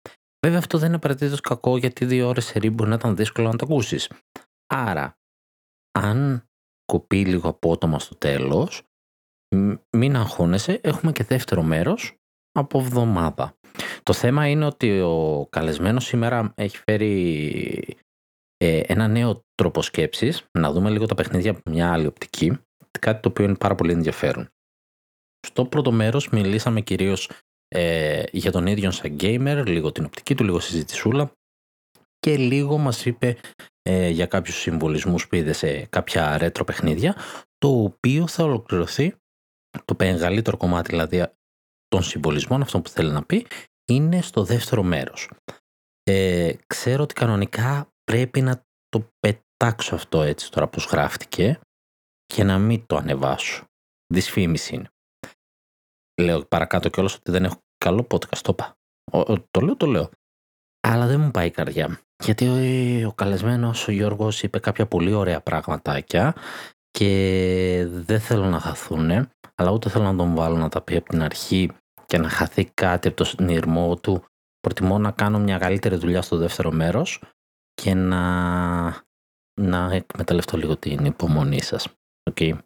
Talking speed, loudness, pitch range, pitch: 150 wpm, -22 LUFS, 85-115 Hz, 95 Hz